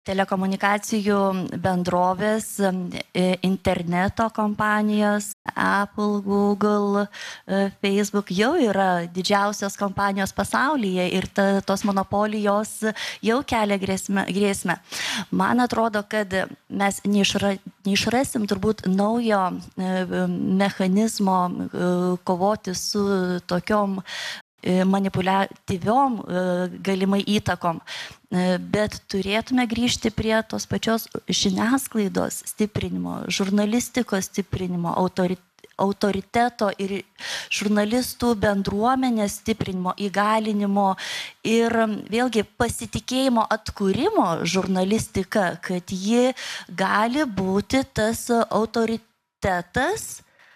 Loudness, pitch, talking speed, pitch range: -23 LUFS, 200 Hz, 70 wpm, 190-215 Hz